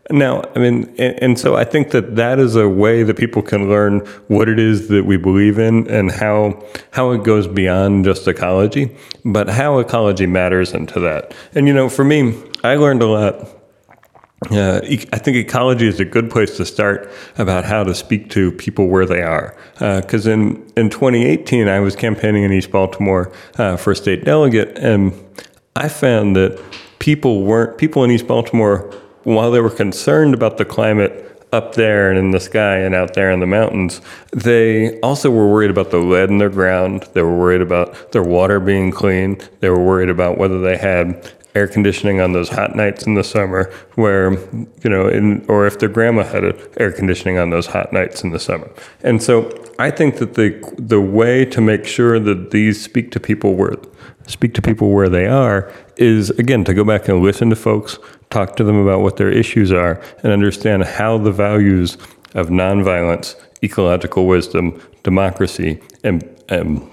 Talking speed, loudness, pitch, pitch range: 195 wpm, -15 LUFS, 105 Hz, 95-115 Hz